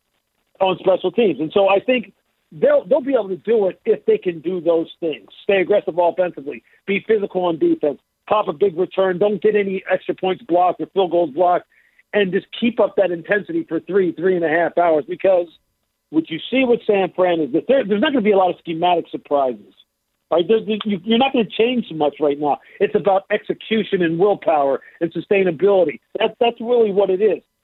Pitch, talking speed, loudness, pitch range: 190 Hz, 205 wpm, -19 LUFS, 170-210 Hz